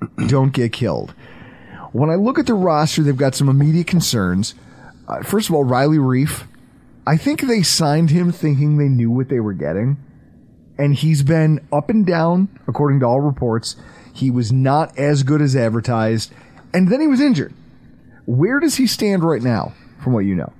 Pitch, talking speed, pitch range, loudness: 140 Hz, 185 wpm, 125-165 Hz, -17 LUFS